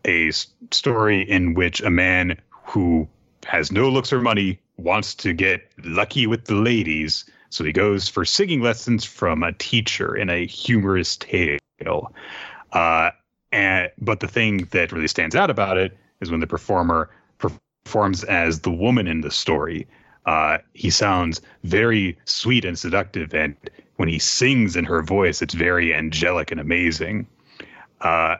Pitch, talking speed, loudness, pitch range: 95 Hz, 160 wpm, -20 LUFS, 85-115 Hz